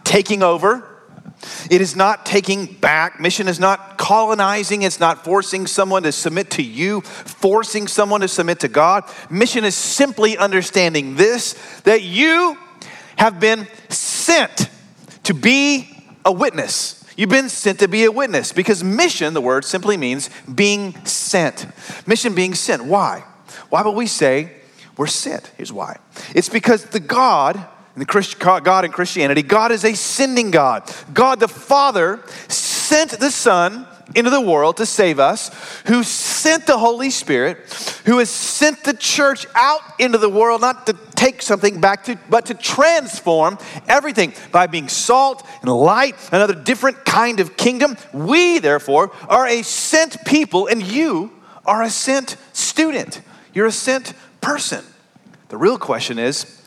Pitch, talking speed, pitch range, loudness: 215 Hz, 155 wpm, 190-250 Hz, -16 LUFS